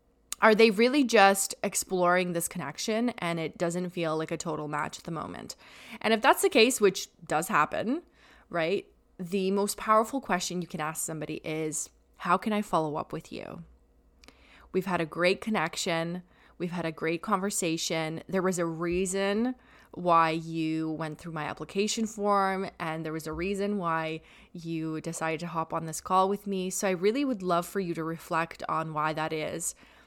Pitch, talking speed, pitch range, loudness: 175 Hz, 185 wpm, 160-200 Hz, -29 LUFS